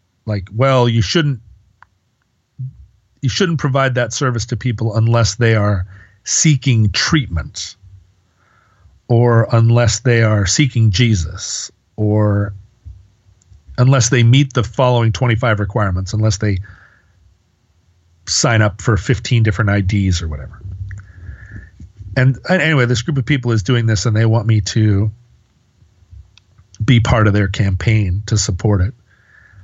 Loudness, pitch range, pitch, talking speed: -15 LUFS, 95-120 Hz, 110 Hz, 125 wpm